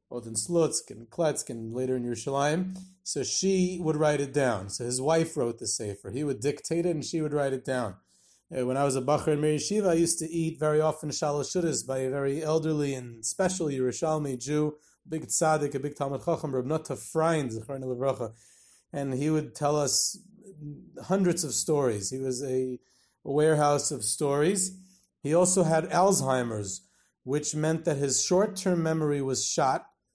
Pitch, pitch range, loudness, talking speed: 150 Hz, 130-160 Hz, -28 LUFS, 180 wpm